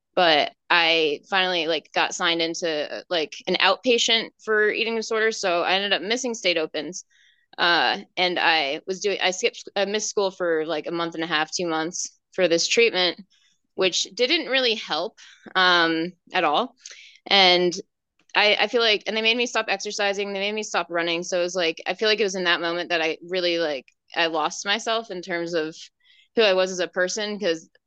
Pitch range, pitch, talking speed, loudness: 170-215 Hz, 185 Hz, 200 wpm, -22 LUFS